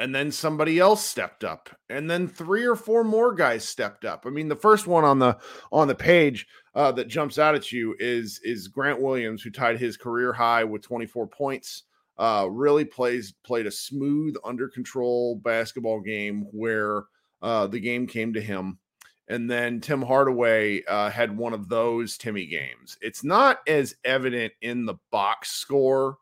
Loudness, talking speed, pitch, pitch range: -24 LUFS, 180 wpm, 120 Hz, 115-145 Hz